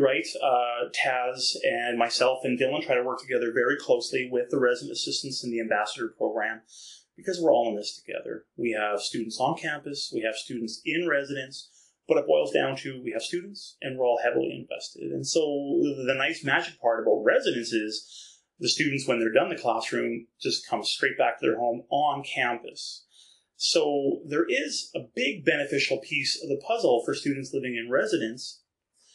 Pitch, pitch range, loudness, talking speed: 125 Hz, 115-140 Hz, -27 LUFS, 185 wpm